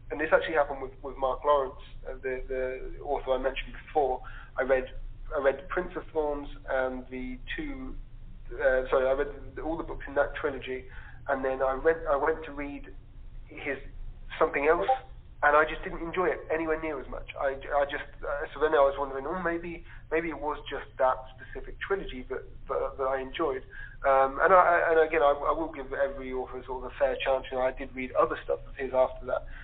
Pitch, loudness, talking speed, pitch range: 135 Hz, -29 LUFS, 220 wpm, 130-155 Hz